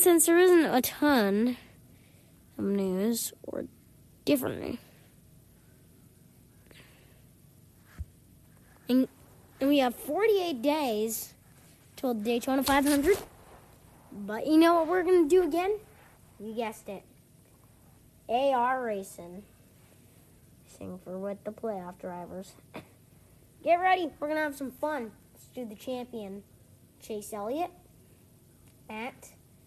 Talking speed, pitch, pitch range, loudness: 100 wpm, 255 Hz, 215-310 Hz, -28 LUFS